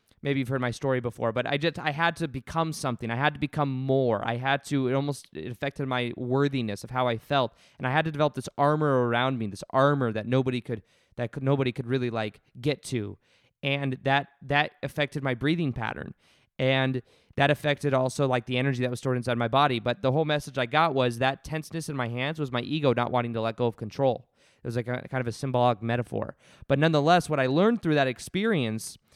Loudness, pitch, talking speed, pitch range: -27 LUFS, 130 Hz, 235 wpm, 125-145 Hz